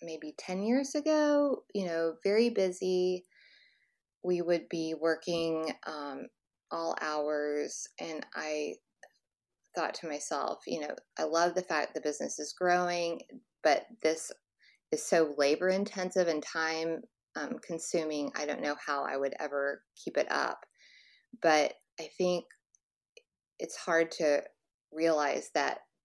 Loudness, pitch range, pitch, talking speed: -32 LUFS, 150-185 Hz, 165 Hz, 130 wpm